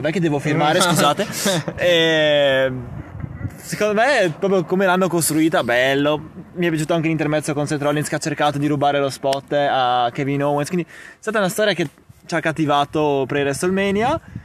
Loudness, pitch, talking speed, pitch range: -19 LUFS, 155 Hz, 175 wpm, 145-175 Hz